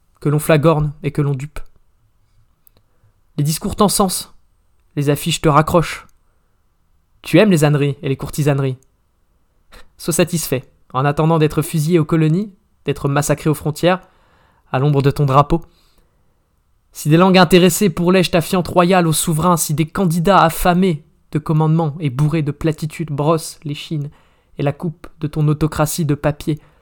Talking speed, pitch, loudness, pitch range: 155 wpm, 150 Hz, -16 LUFS, 140-170 Hz